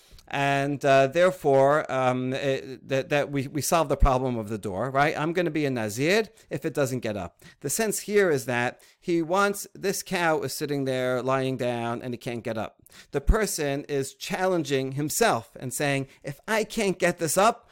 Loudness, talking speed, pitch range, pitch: -26 LUFS, 200 wpm, 130-175 Hz, 140 Hz